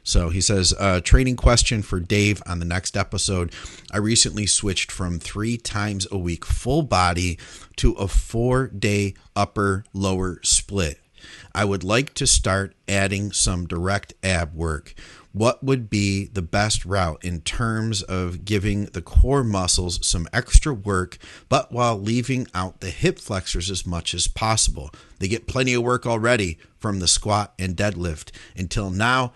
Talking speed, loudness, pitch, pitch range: 160 wpm, -22 LUFS, 100 Hz, 90-110 Hz